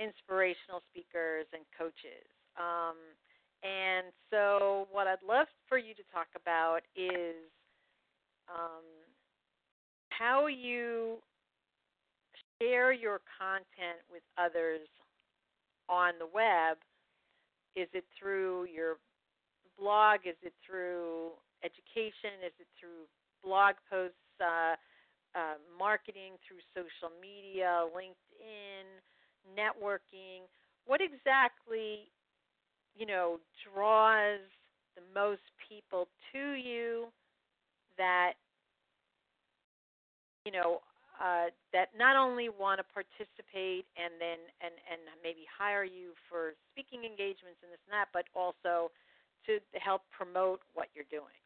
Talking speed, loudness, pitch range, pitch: 105 wpm, -34 LUFS, 170-210 Hz, 185 Hz